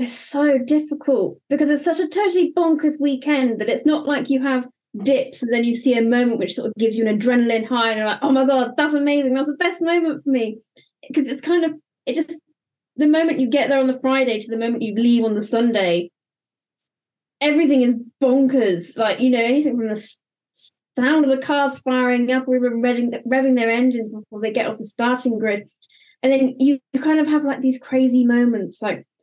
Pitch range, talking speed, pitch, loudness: 235-290 Hz, 210 wpm, 260 Hz, -19 LUFS